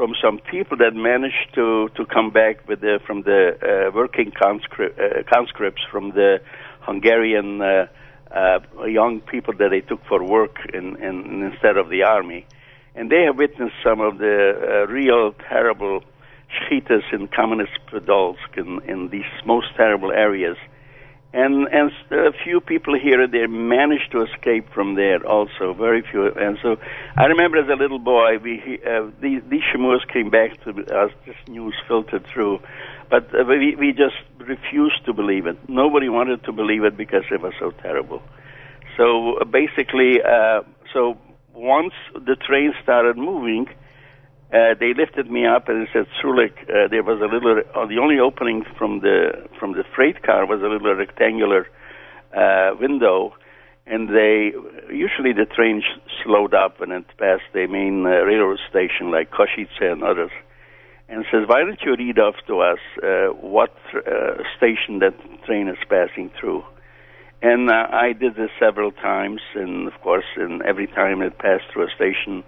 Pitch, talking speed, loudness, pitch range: 120 Hz, 170 wpm, -19 LUFS, 105-140 Hz